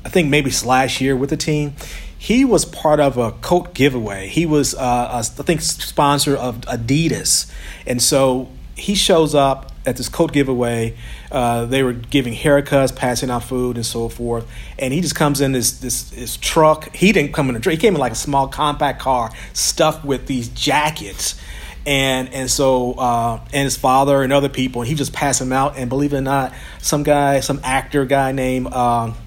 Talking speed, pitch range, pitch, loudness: 205 wpm, 125-145 Hz, 135 Hz, -17 LUFS